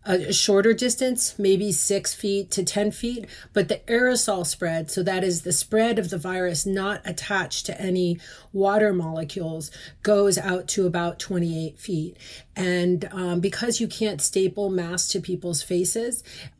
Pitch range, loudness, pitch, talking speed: 180-205 Hz, -23 LUFS, 195 Hz, 155 wpm